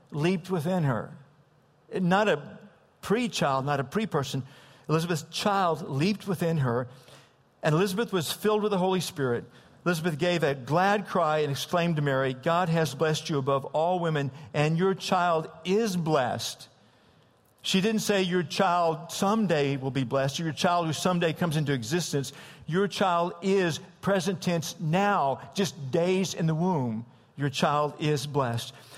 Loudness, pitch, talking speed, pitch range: -27 LUFS, 165 Hz, 160 wpm, 145-185 Hz